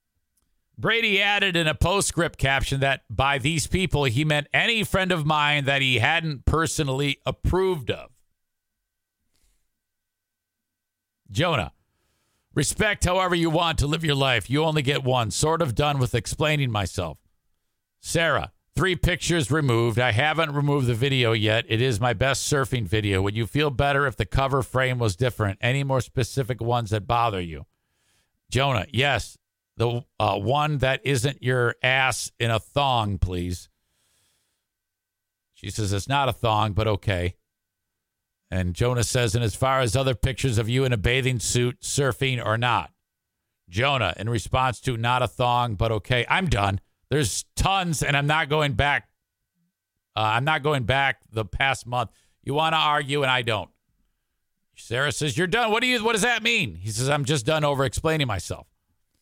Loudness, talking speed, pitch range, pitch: -23 LUFS, 165 wpm, 110-145 Hz, 125 Hz